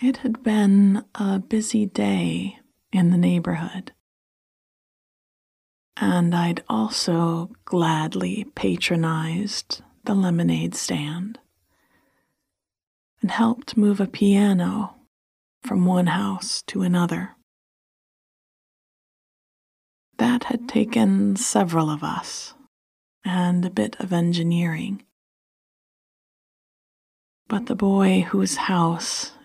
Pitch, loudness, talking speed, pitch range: 190 Hz, -22 LUFS, 90 wpm, 170-215 Hz